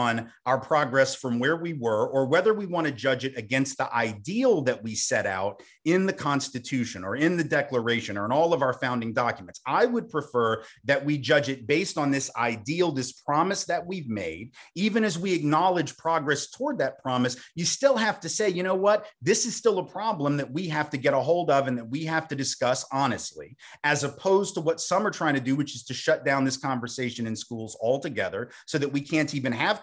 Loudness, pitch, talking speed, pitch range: -26 LUFS, 145 Hz, 225 wpm, 130-170 Hz